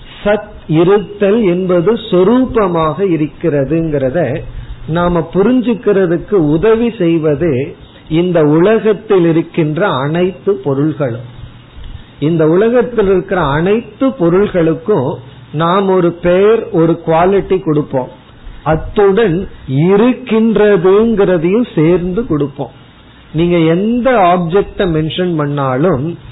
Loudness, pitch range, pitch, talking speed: -12 LUFS, 155-200 Hz, 175 Hz, 75 wpm